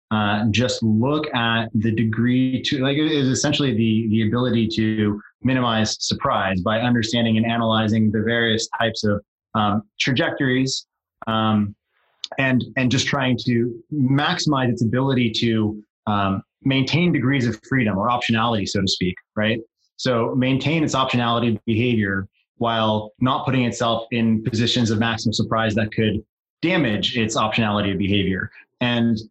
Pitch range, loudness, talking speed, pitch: 110-125 Hz, -21 LUFS, 145 wpm, 115 Hz